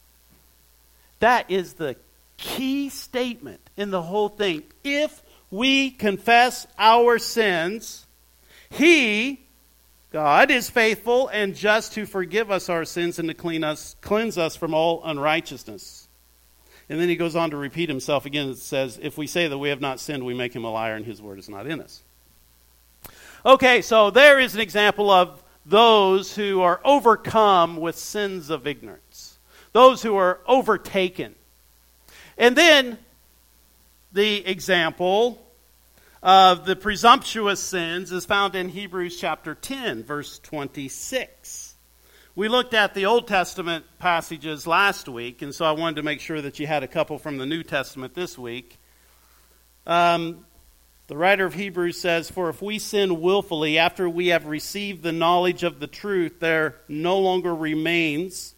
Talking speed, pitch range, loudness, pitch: 155 wpm, 140-205 Hz, -21 LUFS, 170 Hz